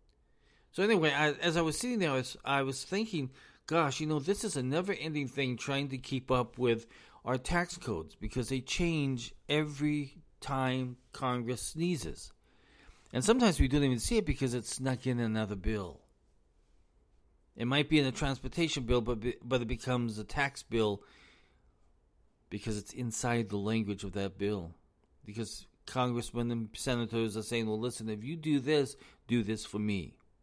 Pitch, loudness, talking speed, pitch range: 125 Hz, -33 LUFS, 175 wpm, 110-145 Hz